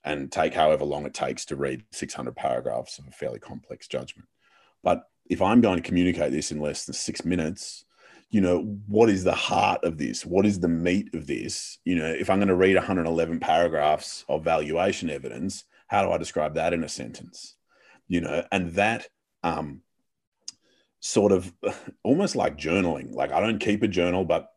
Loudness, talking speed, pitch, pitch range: -25 LUFS, 200 wpm, 90 Hz, 80-95 Hz